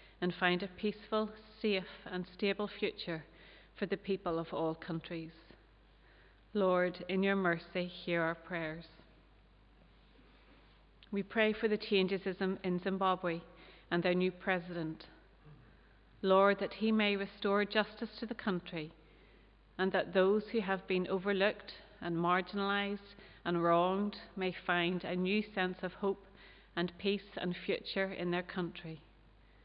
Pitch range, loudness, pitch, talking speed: 175-200 Hz, -35 LUFS, 185 Hz, 135 wpm